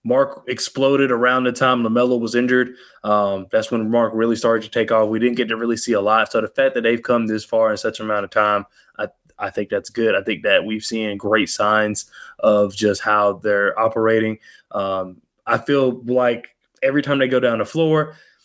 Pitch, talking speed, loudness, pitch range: 115 Hz, 220 wpm, -19 LUFS, 105-125 Hz